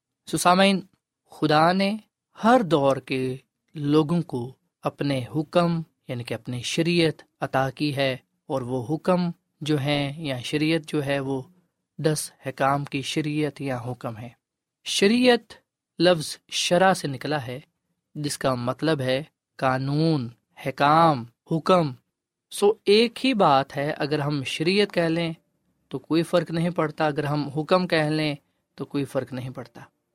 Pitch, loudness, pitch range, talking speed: 150 Hz, -24 LUFS, 135-170 Hz, 145 wpm